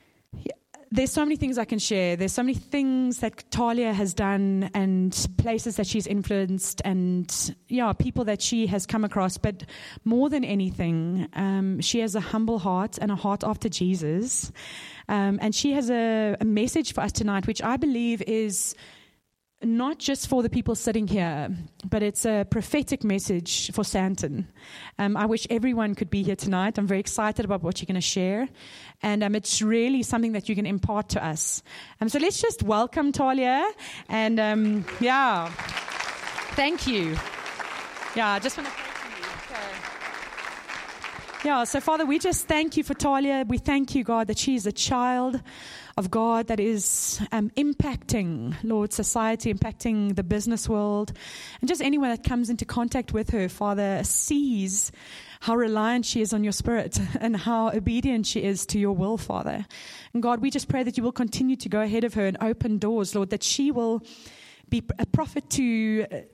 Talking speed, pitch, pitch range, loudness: 180 wpm, 220 Hz, 200-245 Hz, -26 LUFS